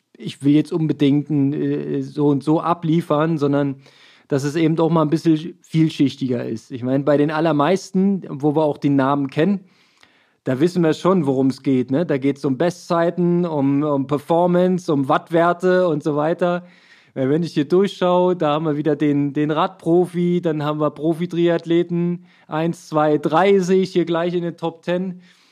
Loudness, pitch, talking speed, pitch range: -19 LUFS, 160 Hz, 180 wpm, 145-175 Hz